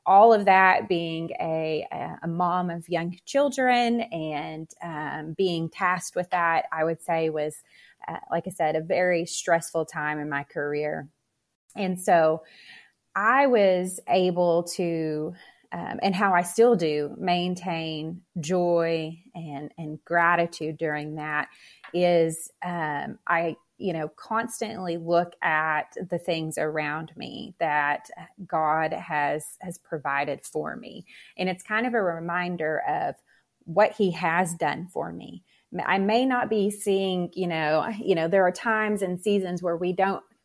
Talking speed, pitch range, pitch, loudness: 145 wpm, 155-185 Hz, 170 Hz, -25 LUFS